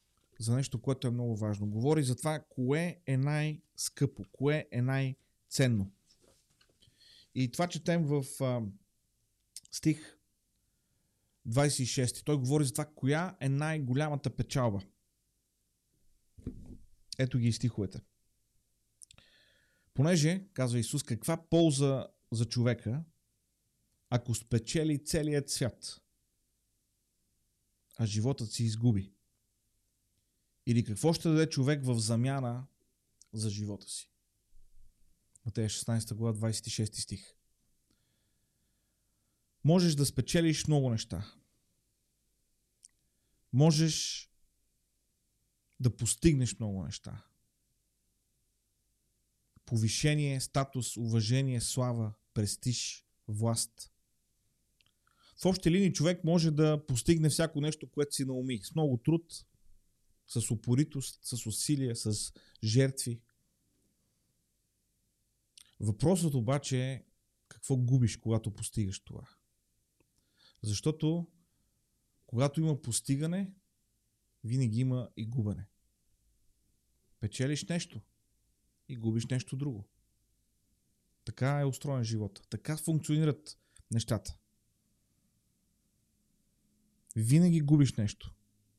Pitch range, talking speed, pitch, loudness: 105-140 Hz, 90 wpm, 120 Hz, -32 LUFS